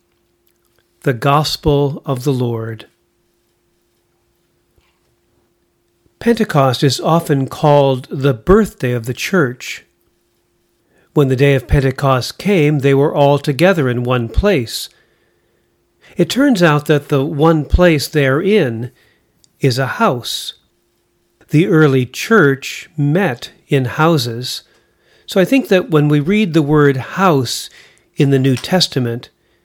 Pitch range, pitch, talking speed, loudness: 125-160 Hz, 140 Hz, 120 wpm, -14 LUFS